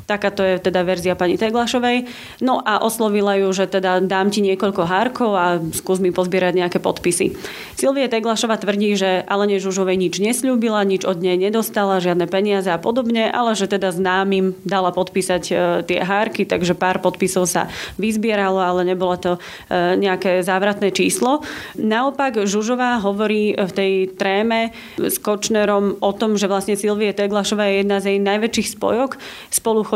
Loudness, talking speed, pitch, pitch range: -18 LUFS, 160 wpm, 200 Hz, 185-215 Hz